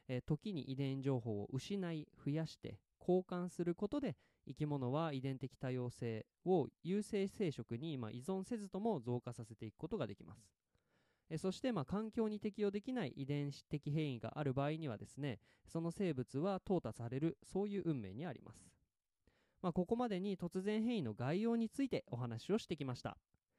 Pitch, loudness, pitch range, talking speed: 150 Hz, -42 LUFS, 125-190 Hz, 345 characters per minute